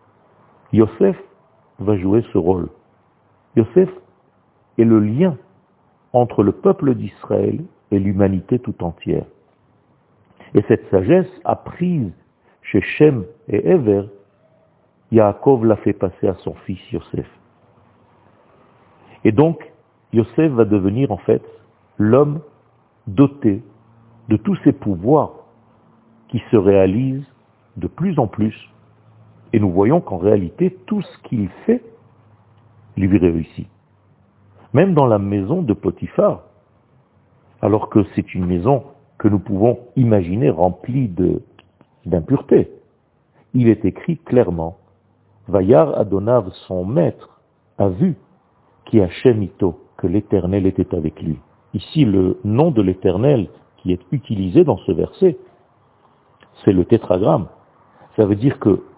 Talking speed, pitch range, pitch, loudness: 120 wpm, 100-130 Hz, 110 Hz, -18 LUFS